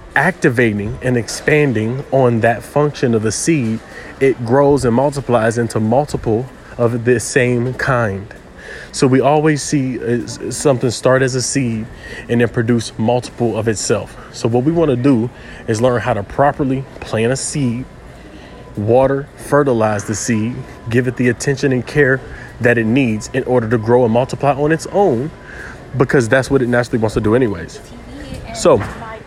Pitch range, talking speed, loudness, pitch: 115-135 Hz, 165 wpm, -16 LUFS, 125 Hz